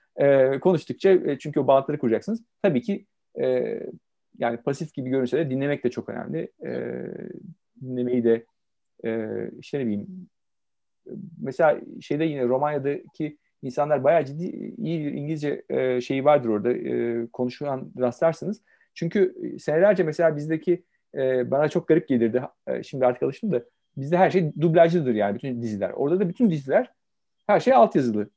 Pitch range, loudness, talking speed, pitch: 125-175 Hz, -24 LUFS, 145 wpm, 145 Hz